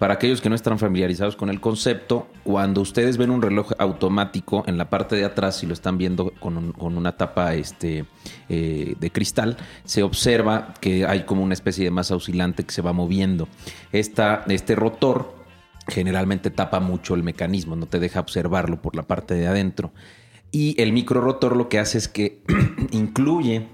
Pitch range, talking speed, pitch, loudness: 90-110 Hz, 190 wpm, 95 Hz, -22 LUFS